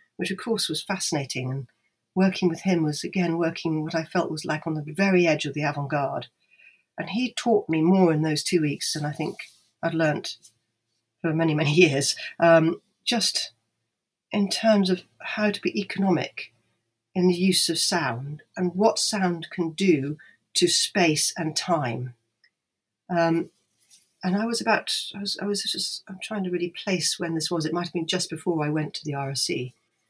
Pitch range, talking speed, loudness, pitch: 150-190 Hz, 185 wpm, -24 LUFS, 170 Hz